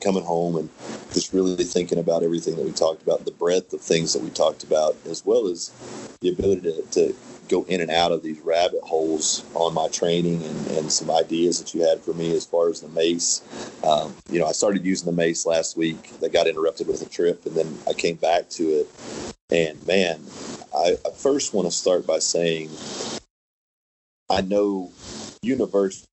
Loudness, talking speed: -23 LUFS, 200 wpm